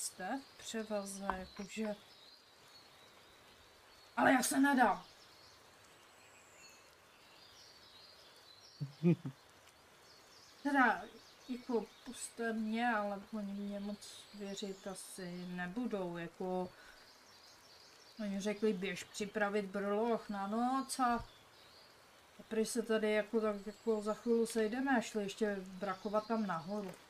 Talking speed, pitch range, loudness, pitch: 95 wpm, 195-225 Hz, -38 LUFS, 210 Hz